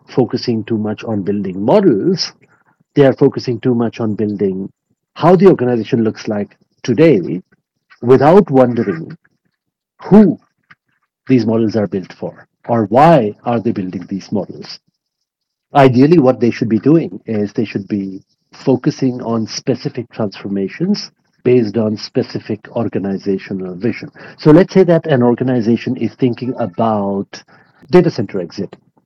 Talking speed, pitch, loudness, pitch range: 135 wpm, 120 Hz, -14 LUFS, 105-130 Hz